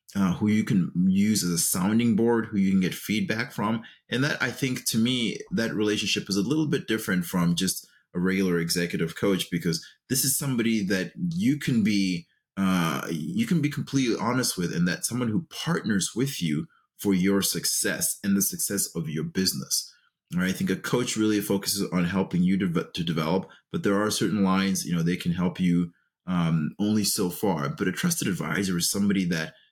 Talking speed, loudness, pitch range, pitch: 205 wpm, -26 LUFS, 90-120 Hz, 100 Hz